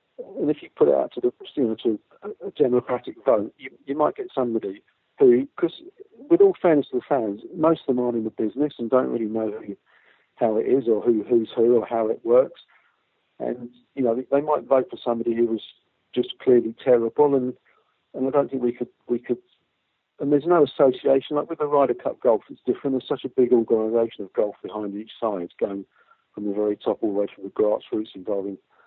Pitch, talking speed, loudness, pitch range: 125 Hz, 220 wpm, -23 LUFS, 115-160 Hz